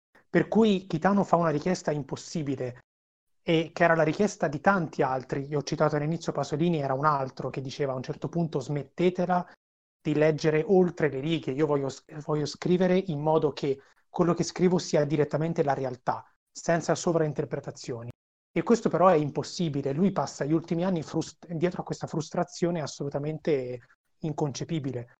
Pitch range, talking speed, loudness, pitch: 145-170 Hz, 160 wpm, -28 LUFS, 155 Hz